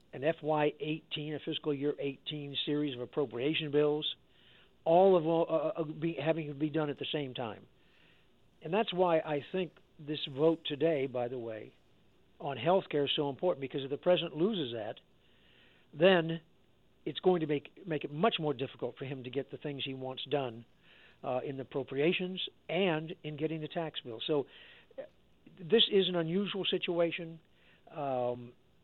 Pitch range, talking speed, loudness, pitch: 140-170 Hz, 170 wpm, -33 LUFS, 150 Hz